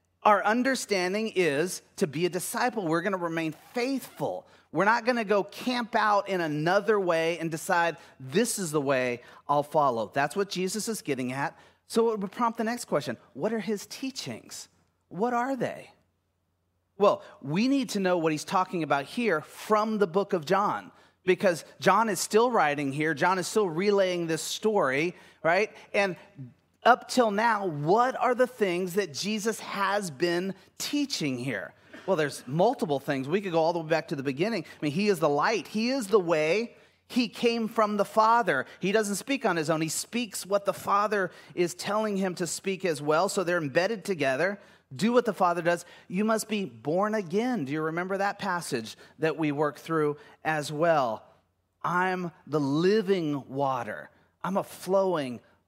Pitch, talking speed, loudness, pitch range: 190 Hz, 185 wpm, -27 LUFS, 155-215 Hz